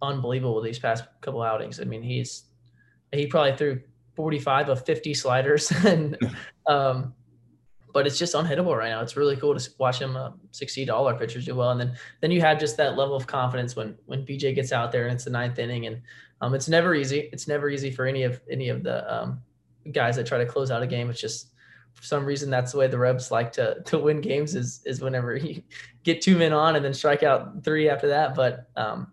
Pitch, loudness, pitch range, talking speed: 135 Hz, -25 LUFS, 120-145 Hz, 230 wpm